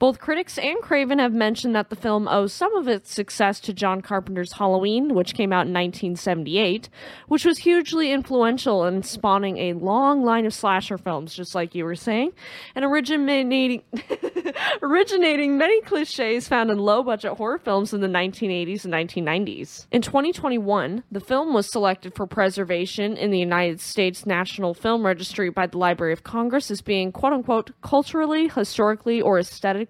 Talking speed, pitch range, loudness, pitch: 165 wpm, 190-265 Hz, -22 LUFS, 210 Hz